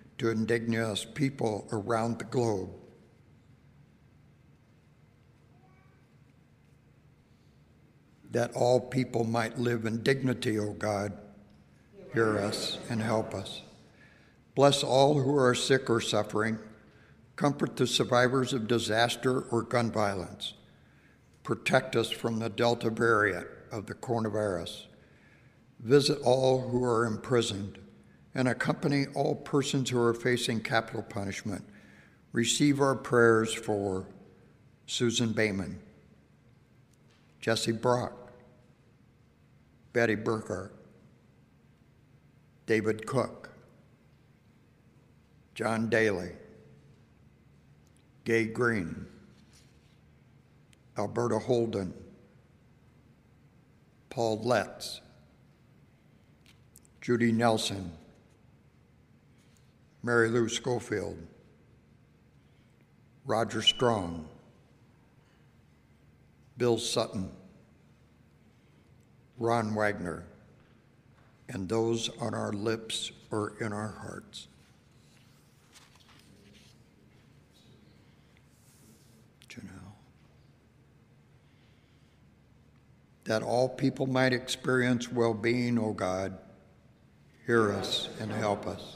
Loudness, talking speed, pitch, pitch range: -30 LUFS, 75 wpm, 115 Hz, 105-125 Hz